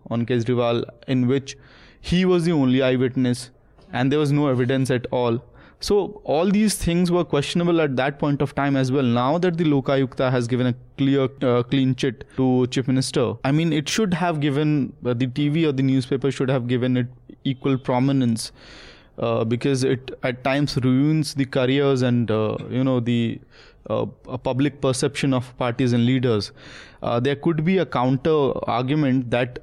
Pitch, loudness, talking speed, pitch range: 135 Hz, -22 LUFS, 180 wpm, 125-145 Hz